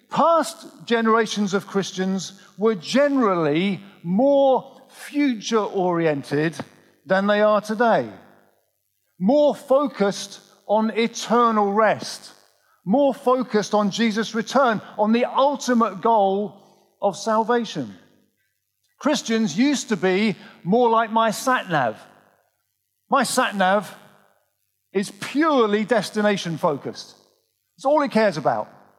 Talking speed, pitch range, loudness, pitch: 100 wpm, 195-245 Hz, -21 LUFS, 220 Hz